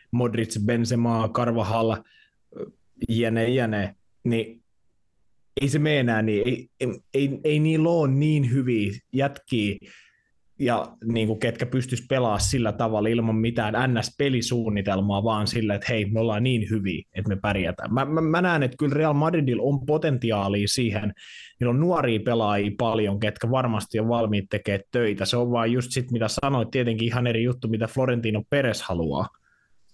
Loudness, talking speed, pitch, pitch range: -24 LUFS, 155 wpm, 115 Hz, 110-130 Hz